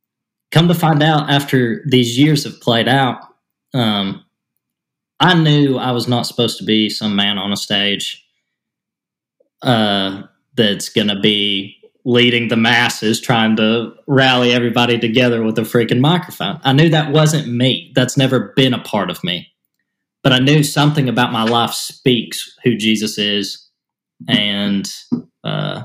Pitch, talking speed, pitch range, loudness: 120 Hz, 155 wpm, 110-135 Hz, -15 LUFS